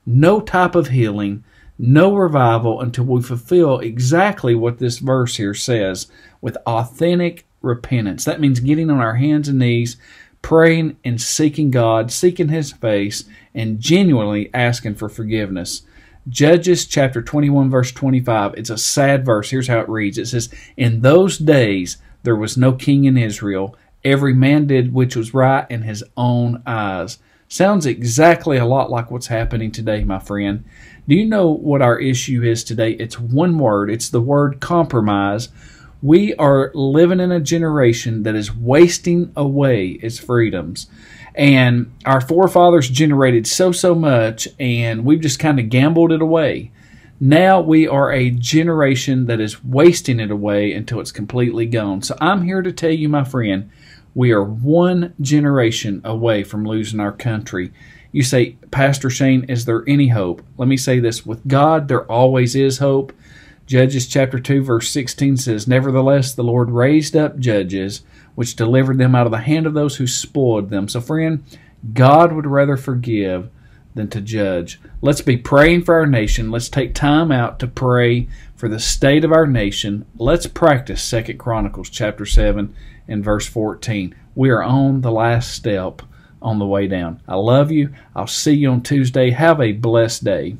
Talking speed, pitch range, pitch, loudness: 170 wpm, 115-145 Hz, 125 Hz, -16 LUFS